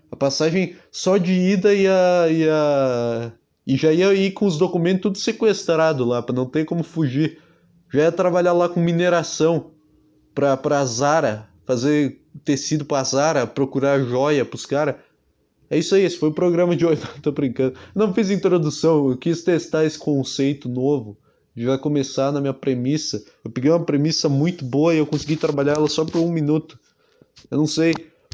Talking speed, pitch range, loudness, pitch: 175 wpm, 140-170 Hz, -20 LUFS, 155 Hz